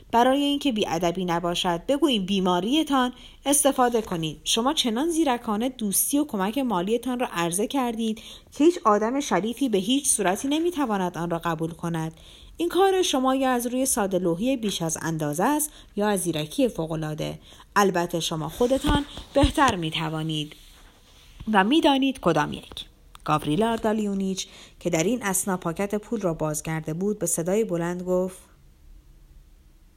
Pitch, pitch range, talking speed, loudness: 195 Hz, 165-255 Hz, 140 wpm, -24 LUFS